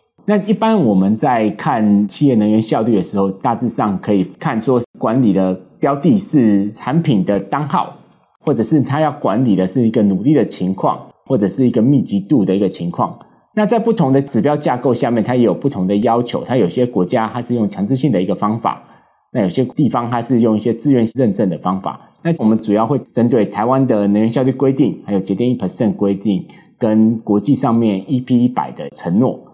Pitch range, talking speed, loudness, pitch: 100-130 Hz, 320 characters per minute, -16 LUFS, 115 Hz